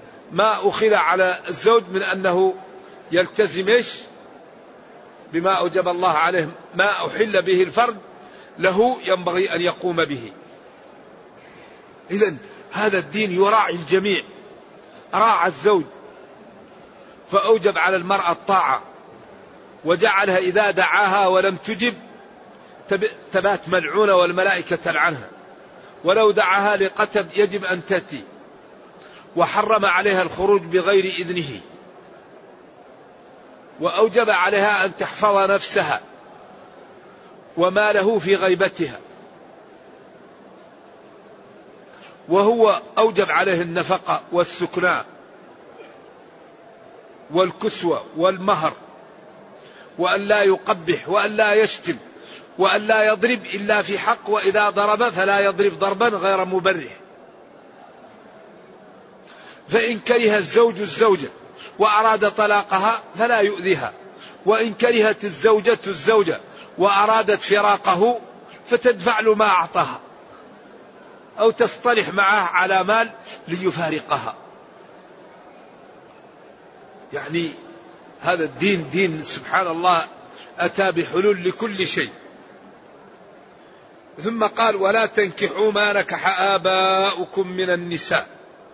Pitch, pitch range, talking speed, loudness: 200 Hz, 185-215 Hz, 85 wpm, -19 LUFS